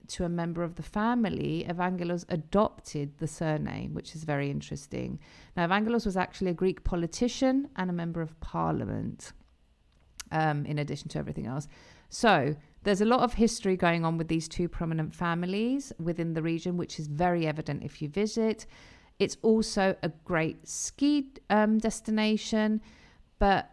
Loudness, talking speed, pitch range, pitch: -30 LUFS, 160 wpm, 155-210 Hz, 175 Hz